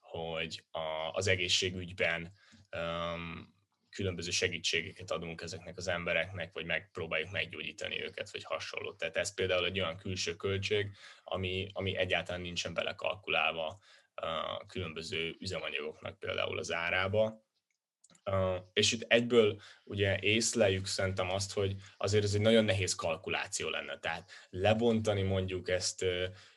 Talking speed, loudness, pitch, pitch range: 115 wpm, -33 LUFS, 95 Hz, 90-105 Hz